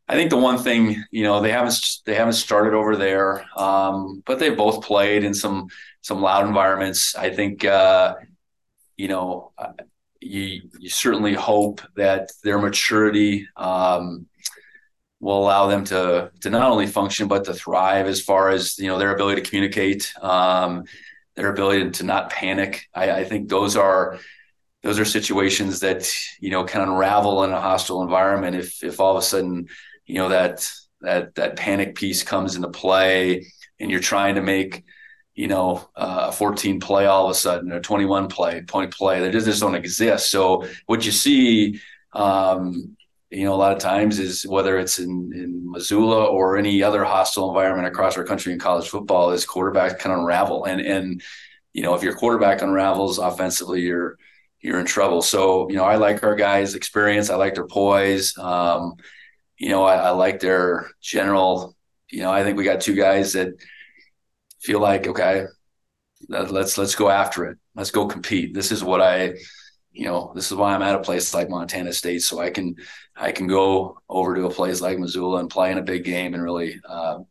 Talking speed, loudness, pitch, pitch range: 190 wpm, -20 LUFS, 95 Hz, 95-100 Hz